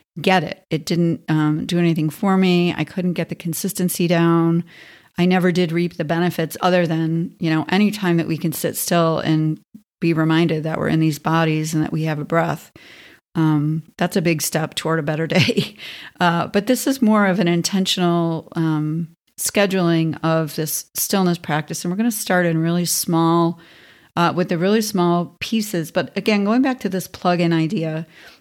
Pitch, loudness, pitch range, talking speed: 170 Hz, -19 LUFS, 160-180 Hz, 190 wpm